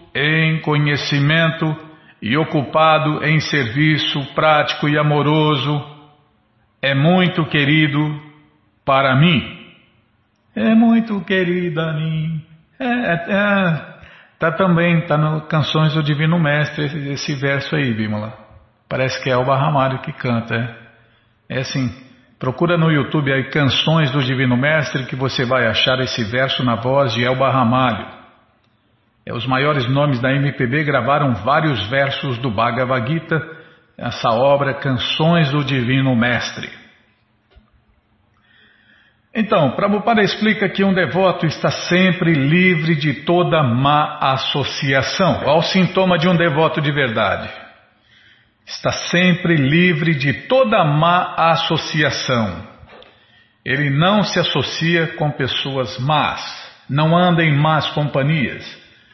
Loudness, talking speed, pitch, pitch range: -17 LUFS, 120 wpm, 150 Hz, 130-165 Hz